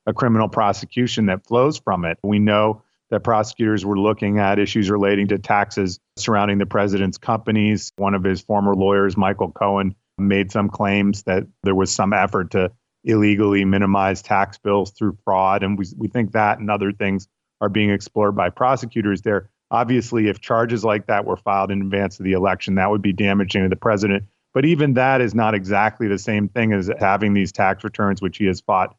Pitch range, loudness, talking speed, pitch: 100-110 Hz, -19 LUFS, 195 wpm, 100 Hz